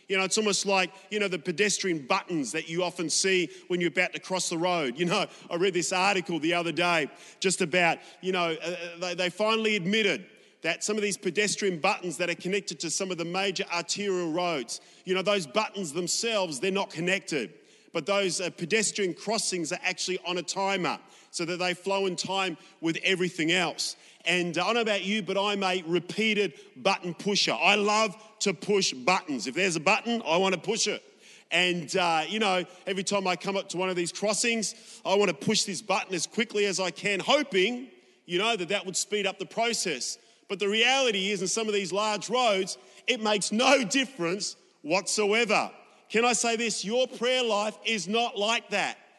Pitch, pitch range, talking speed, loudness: 190 Hz, 180-210 Hz, 205 wpm, -27 LUFS